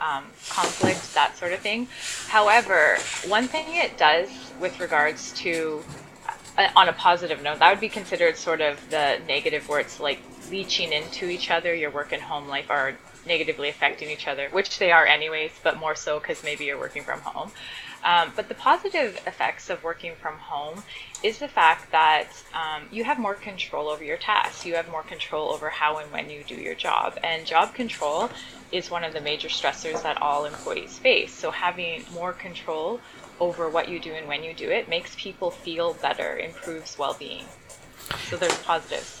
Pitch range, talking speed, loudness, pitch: 155-205 Hz, 190 wpm, -24 LUFS, 170 Hz